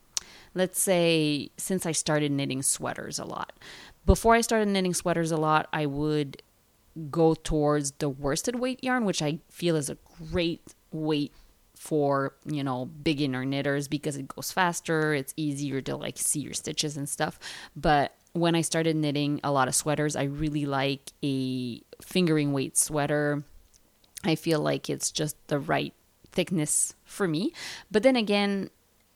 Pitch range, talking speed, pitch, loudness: 140-170 Hz, 160 wpm, 150 Hz, -27 LUFS